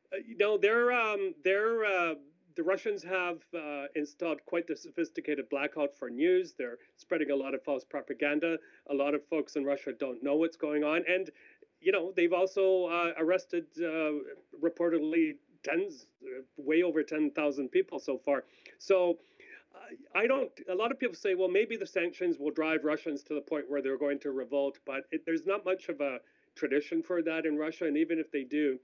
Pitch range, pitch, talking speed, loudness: 150-195 Hz, 165 Hz, 200 wpm, -32 LUFS